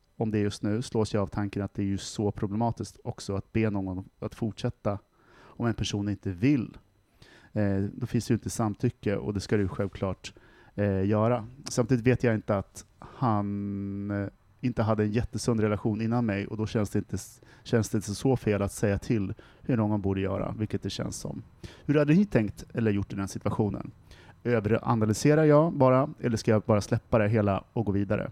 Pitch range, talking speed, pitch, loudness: 100-120 Hz, 200 wpm, 110 Hz, -28 LUFS